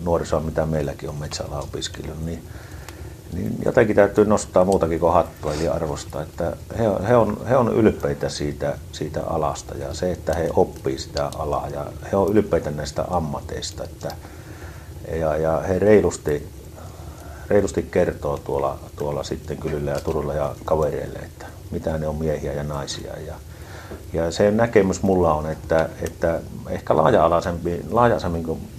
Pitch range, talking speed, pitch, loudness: 75-90 Hz, 145 wpm, 80 Hz, -22 LUFS